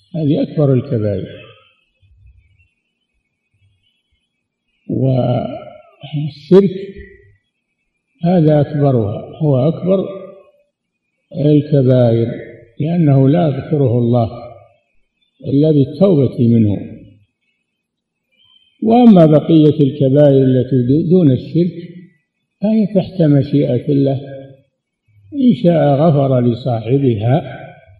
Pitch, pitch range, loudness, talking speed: 140 Hz, 120-165 Hz, -13 LUFS, 65 wpm